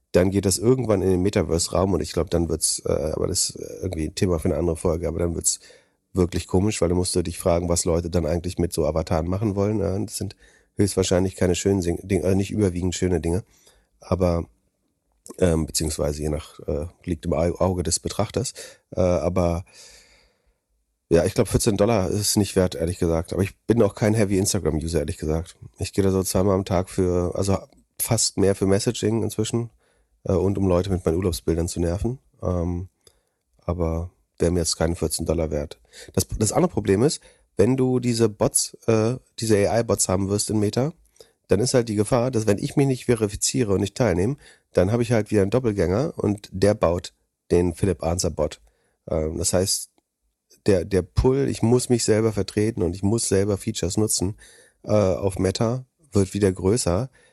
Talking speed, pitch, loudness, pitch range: 195 wpm, 95 Hz, -23 LUFS, 85-105 Hz